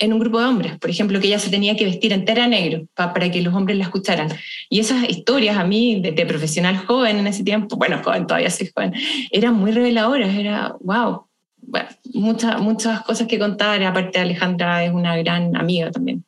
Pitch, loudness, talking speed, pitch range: 210 Hz, -19 LUFS, 210 wpm, 180-225 Hz